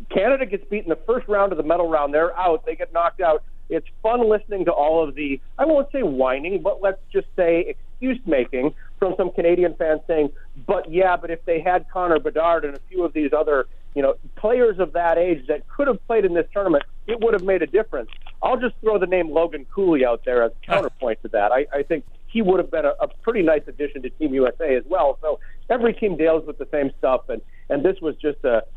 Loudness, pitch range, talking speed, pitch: -21 LUFS, 150-210 Hz, 240 wpm, 170 Hz